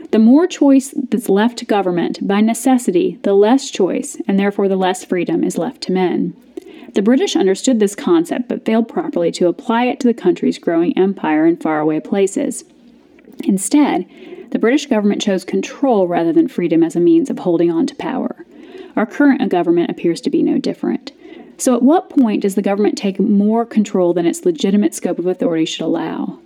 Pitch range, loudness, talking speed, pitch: 200-310 Hz, -16 LUFS, 190 wpm, 245 Hz